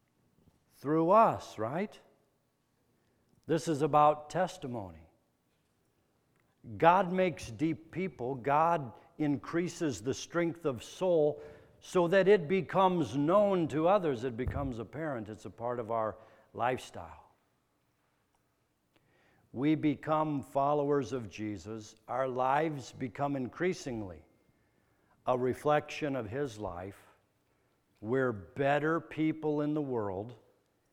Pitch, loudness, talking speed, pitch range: 140 Hz, -32 LUFS, 105 wpm, 115-155 Hz